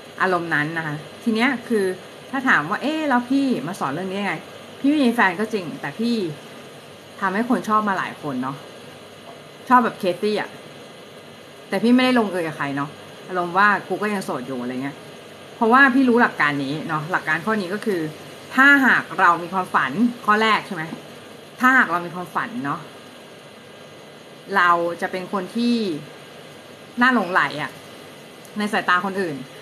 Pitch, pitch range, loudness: 200 Hz, 175-240 Hz, -20 LUFS